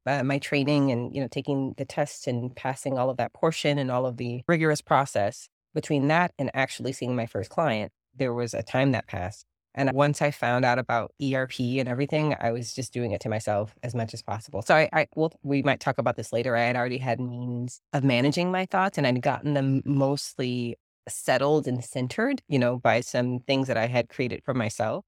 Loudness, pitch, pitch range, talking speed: -26 LUFS, 130 Hz, 120-145 Hz, 225 wpm